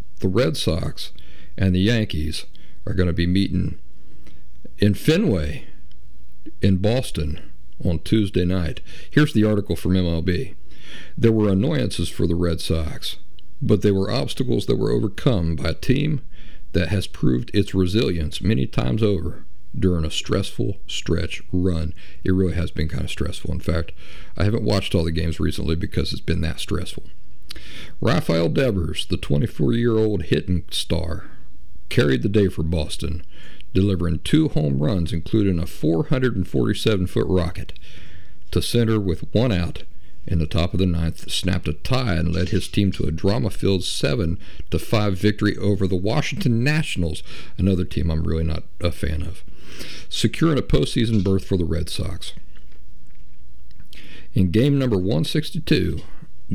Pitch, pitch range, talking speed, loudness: 90 Hz, 80-100 Hz, 150 wpm, -22 LUFS